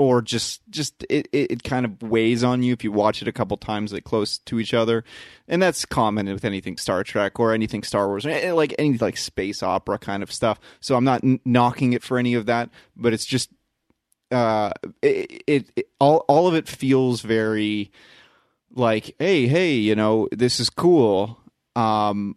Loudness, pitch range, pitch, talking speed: -22 LUFS, 110-130 Hz, 120 Hz, 200 wpm